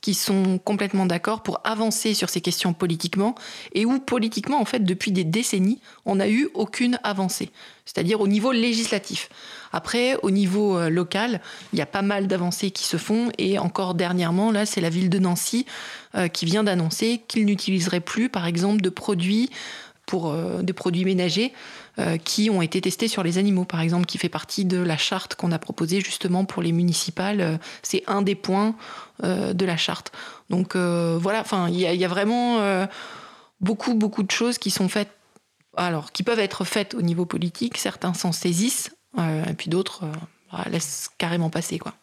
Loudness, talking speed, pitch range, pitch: -24 LUFS, 180 wpm, 180-215 Hz, 195 Hz